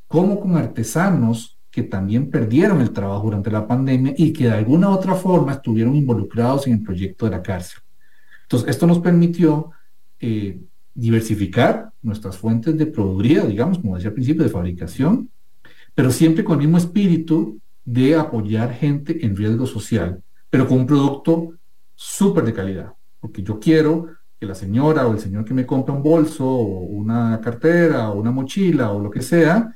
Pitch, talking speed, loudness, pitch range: 125 Hz, 175 wpm, -18 LUFS, 110-160 Hz